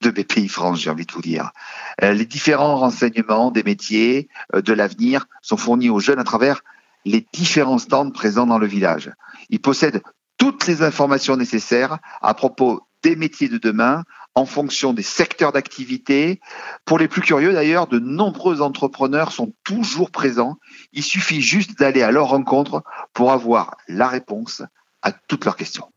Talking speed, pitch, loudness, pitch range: 165 wpm, 140 Hz, -18 LUFS, 120-175 Hz